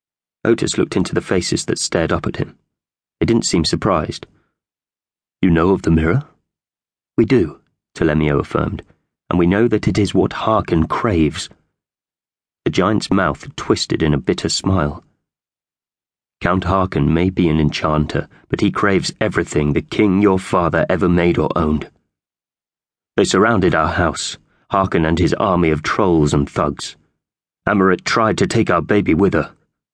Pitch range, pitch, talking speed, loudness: 75-95 Hz, 85 Hz, 155 wpm, -17 LUFS